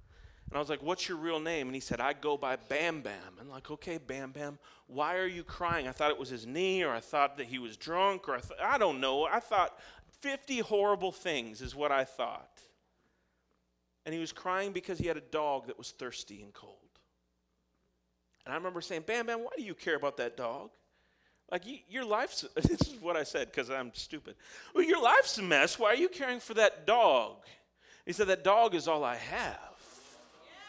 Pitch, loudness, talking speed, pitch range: 155 Hz, -32 LUFS, 220 wpm, 130-190 Hz